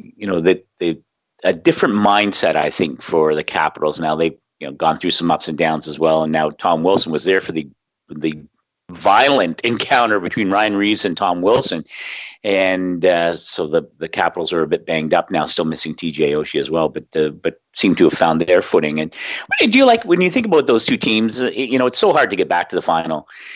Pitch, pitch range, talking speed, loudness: 85 Hz, 80-105 Hz, 230 wpm, -17 LUFS